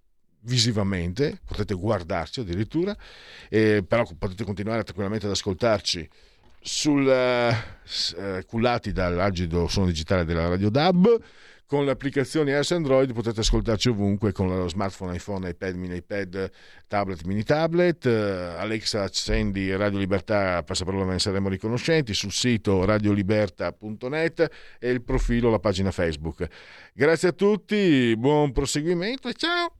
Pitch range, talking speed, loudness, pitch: 95-130 Hz, 125 wpm, -24 LUFS, 105 Hz